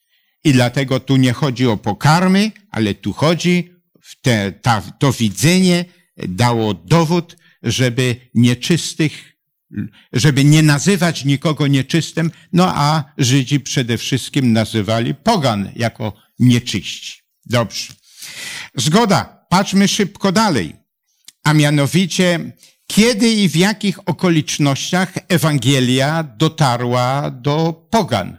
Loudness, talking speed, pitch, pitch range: -16 LUFS, 105 wpm, 150 Hz, 125-175 Hz